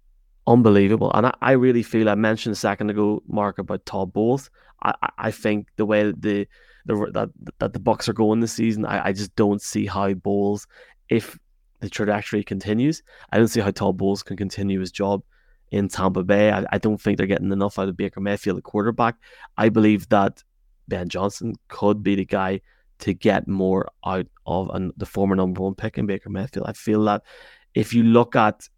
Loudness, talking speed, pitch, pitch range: -22 LUFS, 205 wpm, 105 Hz, 100-110 Hz